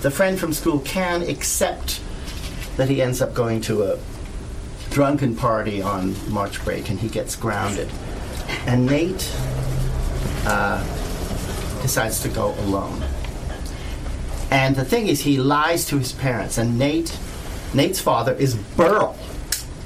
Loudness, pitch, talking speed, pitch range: -22 LUFS, 110 Hz, 135 wpm, 80-135 Hz